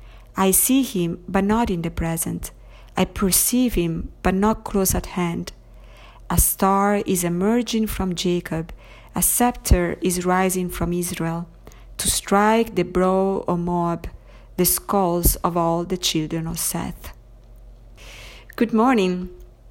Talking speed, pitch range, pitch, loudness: 135 wpm, 170-195 Hz, 180 Hz, -21 LUFS